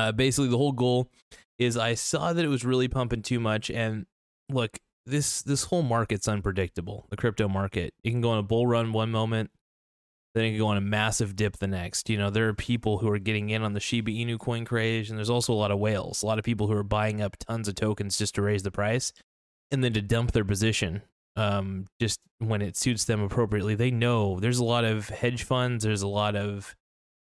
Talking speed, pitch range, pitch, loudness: 235 wpm, 105-120 Hz, 110 Hz, -27 LUFS